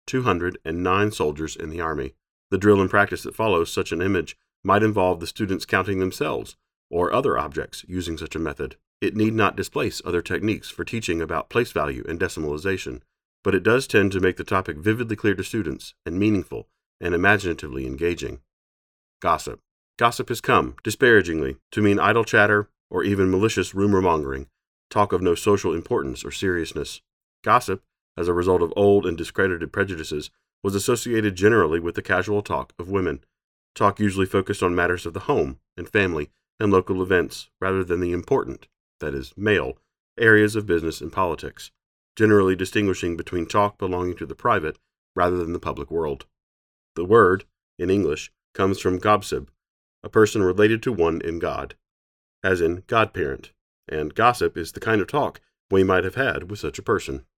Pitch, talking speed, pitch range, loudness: 95 Hz, 175 wpm, 85-105 Hz, -22 LUFS